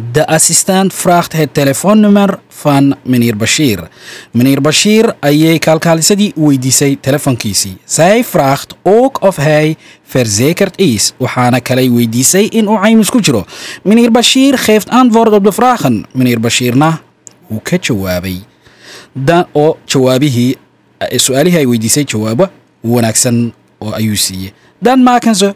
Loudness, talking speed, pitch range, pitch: -10 LUFS, 95 wpm, 125-200 Hz, 150 Hz